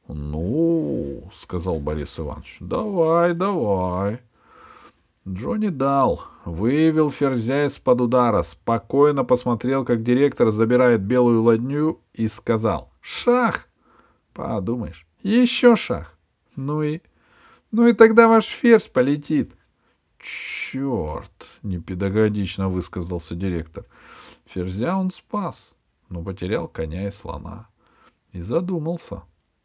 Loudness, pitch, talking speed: -21 LUFS, 120 Hz, 95 wpm